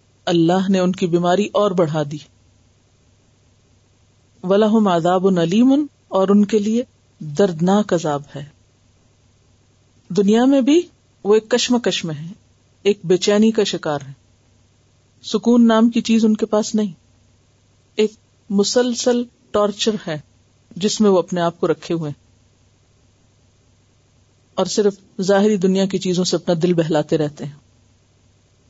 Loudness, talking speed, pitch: -18 LUFS, 135 wpm, 170 Hz